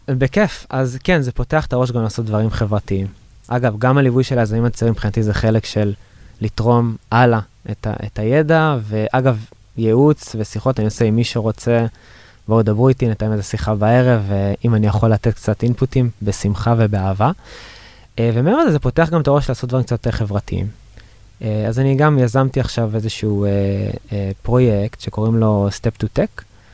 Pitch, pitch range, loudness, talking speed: 115 Hz, 105-125 Hz, -17 LUFS, 165 wpm